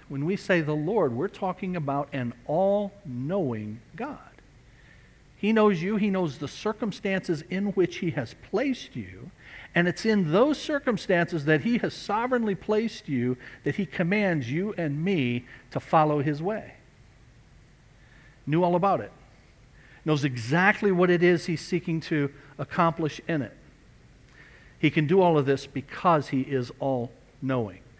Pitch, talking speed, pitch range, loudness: 165 Hz, 155 wpm, 140-195 Hz, -26 LUFS